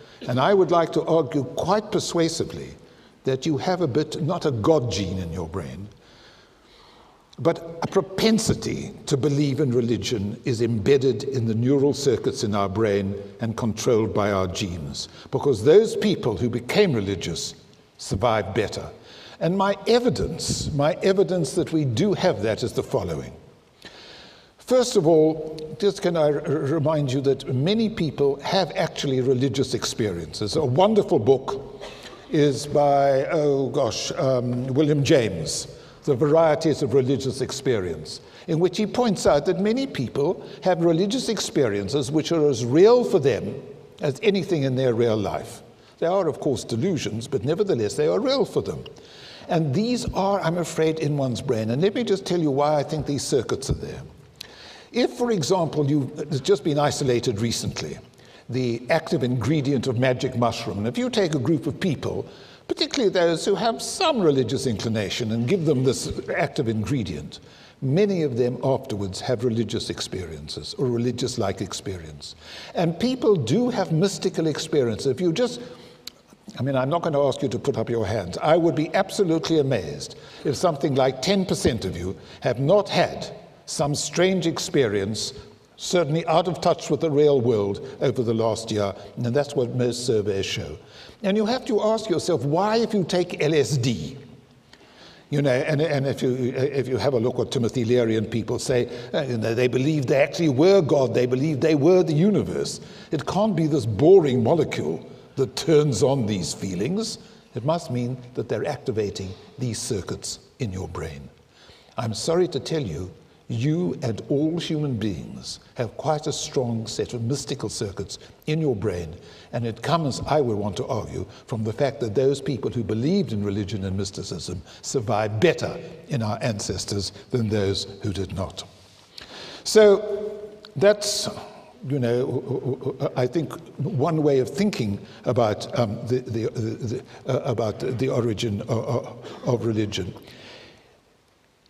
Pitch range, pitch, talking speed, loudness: 115-165 Hz, 140 Hz, 165 wpm, -23 LUFS